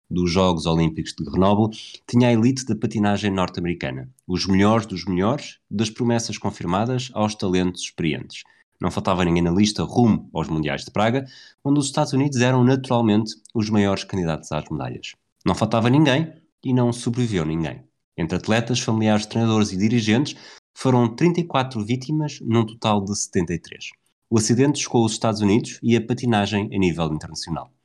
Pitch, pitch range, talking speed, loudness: 110 Hz, 90-120 Hz, 160 wpm, -21 LUFS